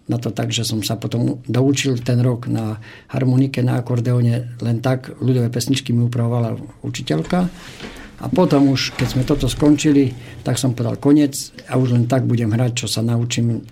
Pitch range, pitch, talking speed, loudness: 120-135 Hz, 125 Hz, 180 wpm, -19 LUFS